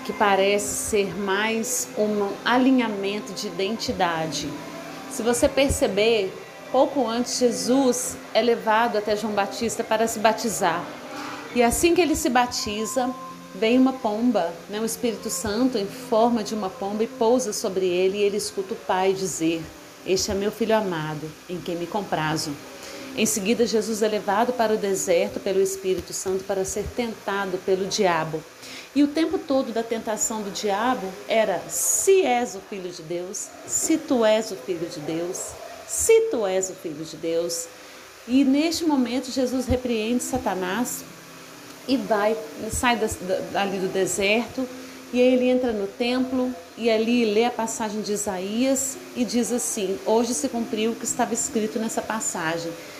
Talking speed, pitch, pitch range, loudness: 160 wpm, 220 Hz, 195-245 Hz, -24 LUFS